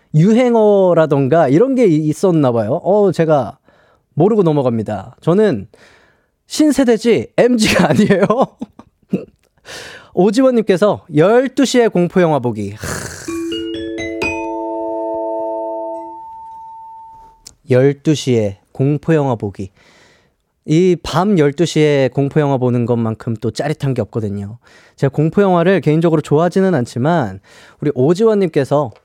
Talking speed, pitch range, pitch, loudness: 225 characters per minute, 120-195 Hz, 150 Hz, -15 LUFS